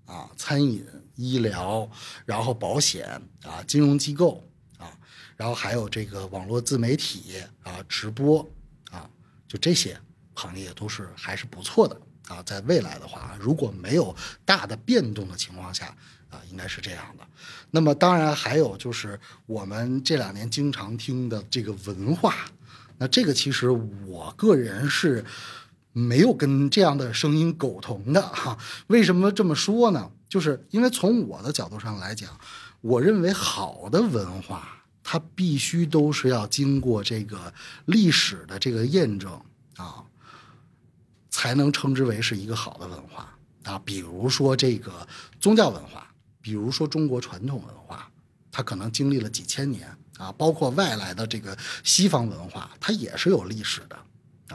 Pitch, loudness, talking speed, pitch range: 125 Hz, -24 LUFS, 235 characters per minute, 105-150 Hz